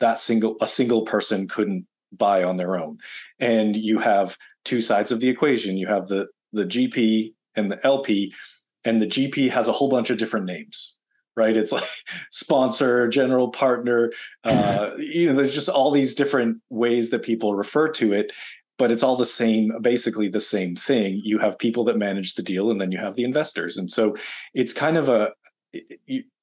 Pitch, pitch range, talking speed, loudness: 115 Hz, 105-135 Hz, 195 wpm, -22 LUFS